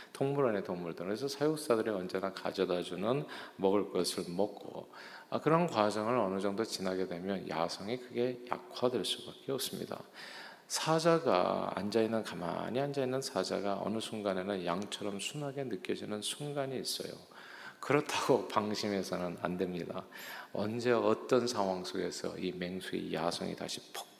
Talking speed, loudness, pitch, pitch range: 330 characters per minute, -35 LUFS, 105 Hz, 95-125 Hz